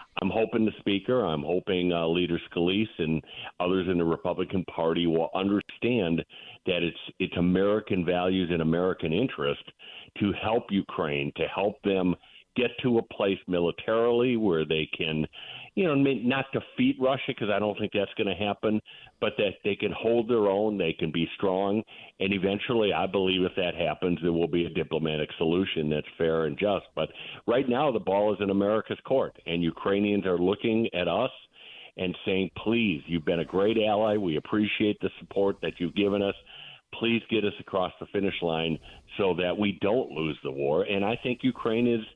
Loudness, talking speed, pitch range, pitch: -27 LUFS, 185 wpm, 85-105 Hz, 95 Hz